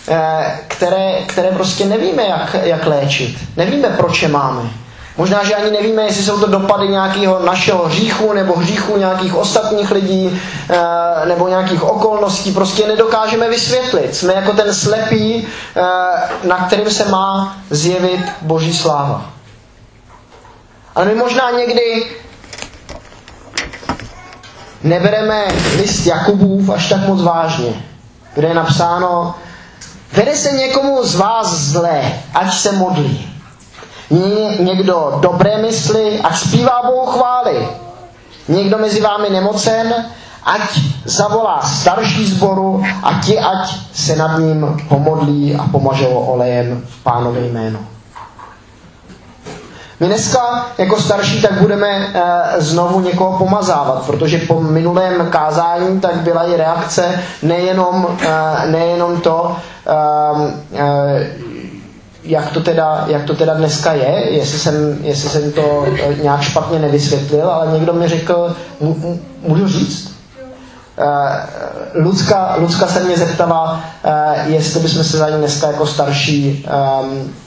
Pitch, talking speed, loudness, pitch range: 170 Hz, 125 wpm, -14 LUFS, 150-200 Hz